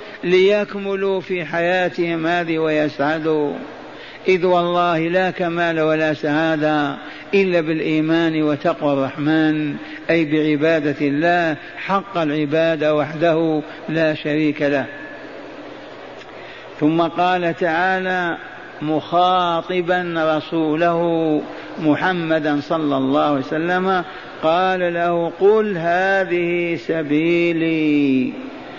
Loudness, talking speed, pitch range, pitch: -18 LUFS, 80 wpm, 155-175 Hz, 165 Hz